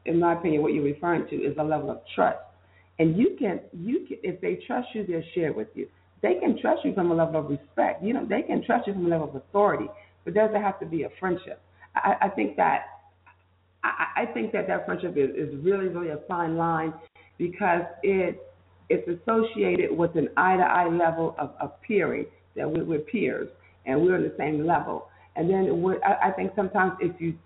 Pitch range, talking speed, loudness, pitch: 155-190 Hz, 210 wpm, -26 LUFS, 170 Hz